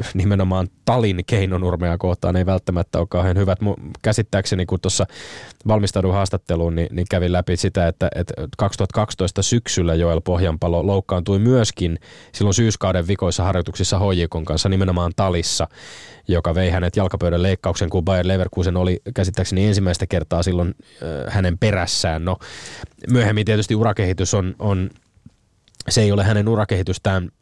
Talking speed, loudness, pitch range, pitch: 135 wpm, -20 LUFS, 90-100 Hz, 95 Hz